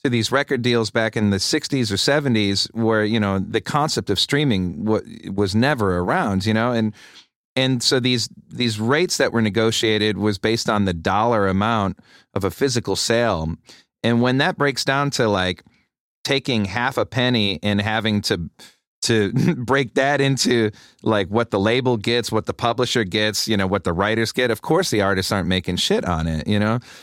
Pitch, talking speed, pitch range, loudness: 110 Hz, 190 wpm, 100-125 Hz, -20 LUFS